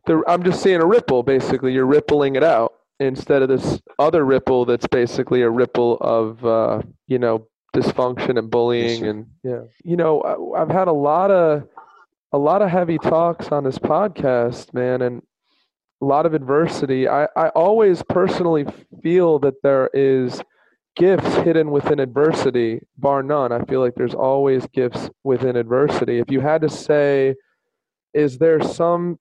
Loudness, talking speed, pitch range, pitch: -18 LUFS, 160 wpm, 125-155 Hz, 135 Hz